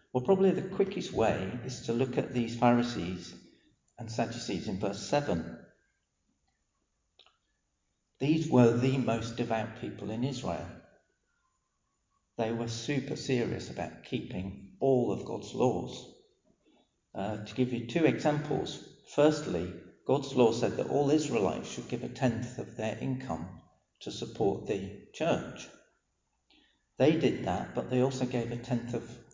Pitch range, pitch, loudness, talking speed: 110-130 Hz, 120 Hz, -31 LUFS, 140 wpm